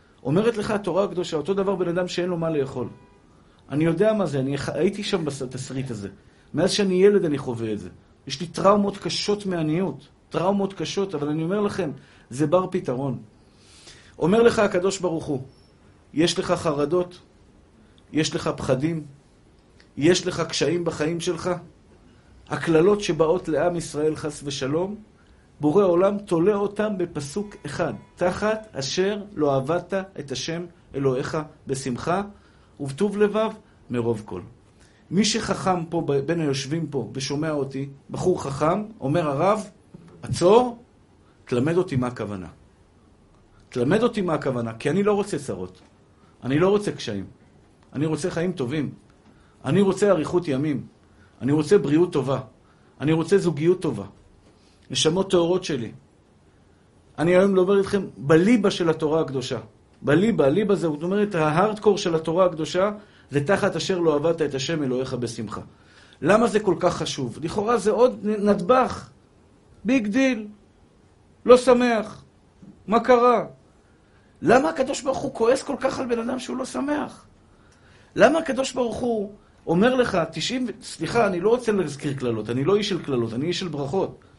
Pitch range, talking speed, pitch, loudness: 135-200 Hz, 150 wpm, 165 Hz, -23 LUFS